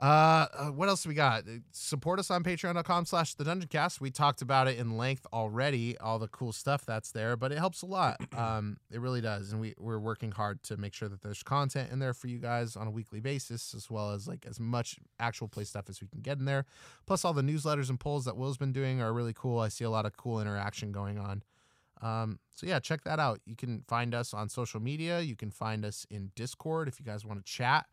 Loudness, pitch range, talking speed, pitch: -34 LUFS, 110-145 Hz, 245 wpm, 120 Hz